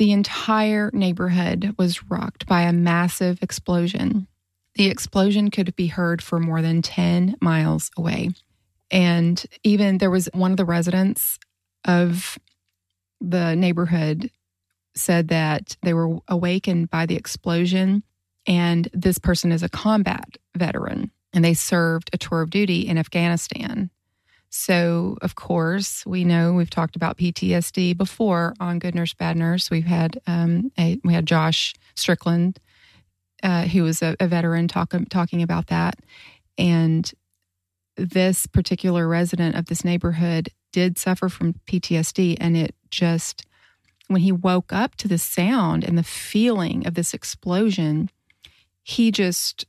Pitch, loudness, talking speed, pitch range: 175 Hz, -21 LUFS, 140 wpm, 165-185 Hz